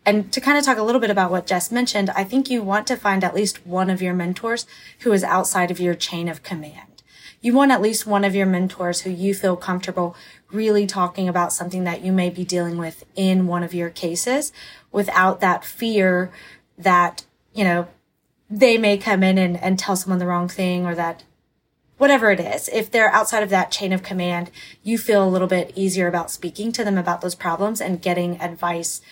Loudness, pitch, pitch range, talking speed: -20 LUFS, 185 Hz, 175-210 Hz, 215 wpm